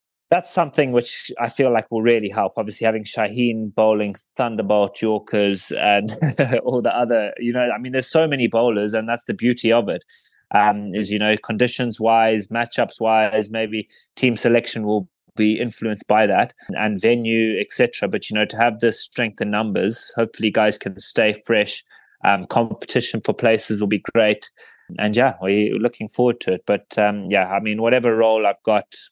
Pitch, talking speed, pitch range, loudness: 110 Hz, 185 wpm, 105-120 Hz, -19 LUFS